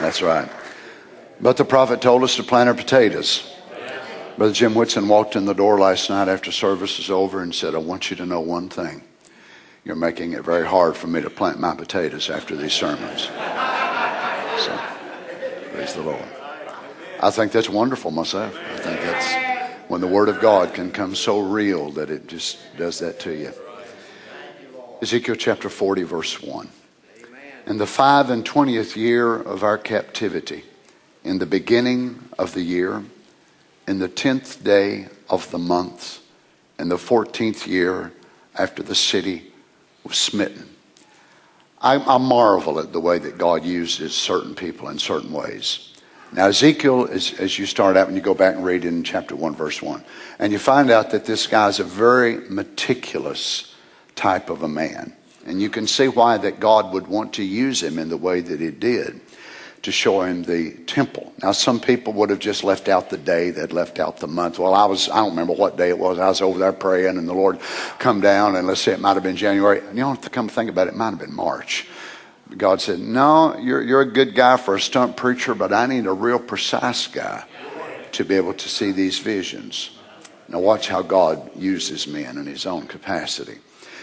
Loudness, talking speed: -20 LUFS, 195 wpm